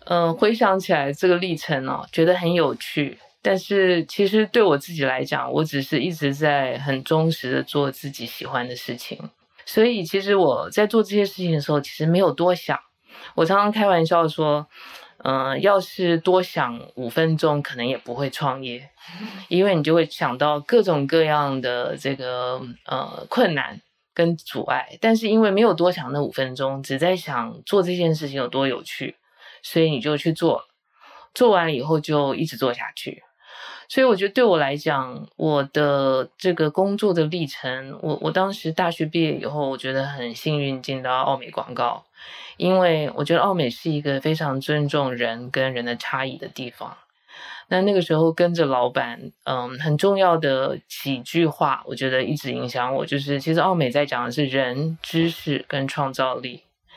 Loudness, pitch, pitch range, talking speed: -22 LUFS, 155 Hz, 135-175 Hz, 265 characters per minute